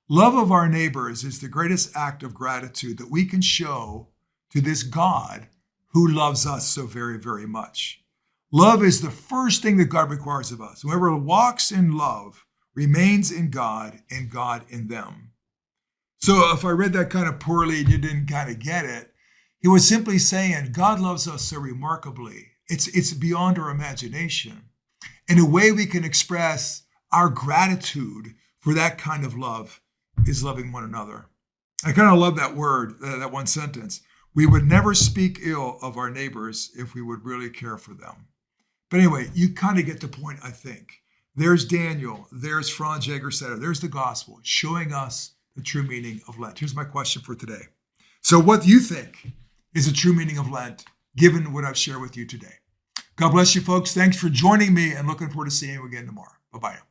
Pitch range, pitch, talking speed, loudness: 125-175 Hz, 150 Hz, 190 wpm, -21 LUFS